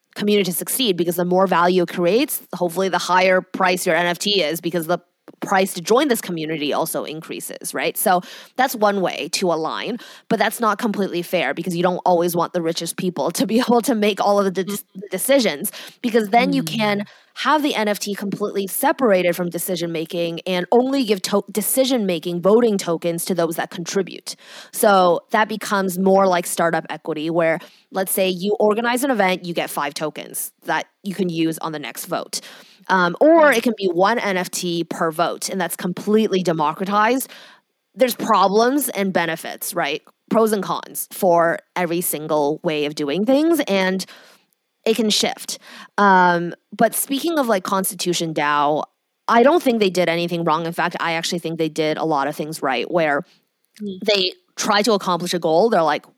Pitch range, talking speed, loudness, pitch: 175-215 Hz, 185 wpm, -19 LUFS, 190 Hz